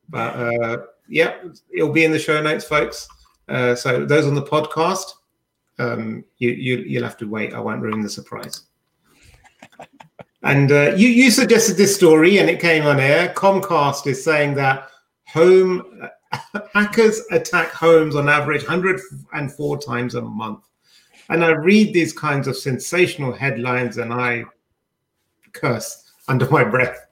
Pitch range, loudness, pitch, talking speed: 125-175 Hz, -17 LUFS, 145 Hz, 150 wpm